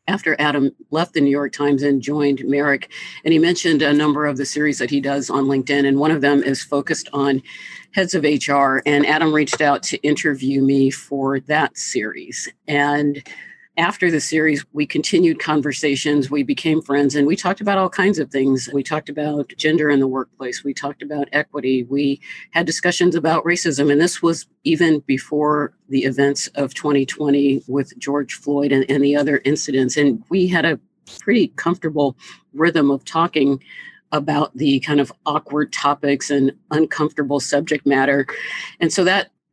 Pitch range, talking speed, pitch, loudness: 140-155 Hz, 175 wpm, 145 Hz, -18 LUFS